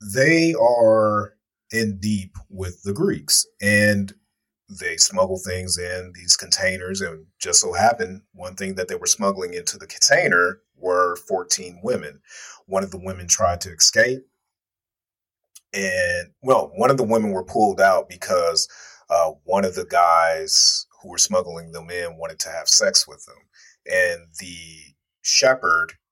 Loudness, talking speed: -19 LUFS, 155 wpm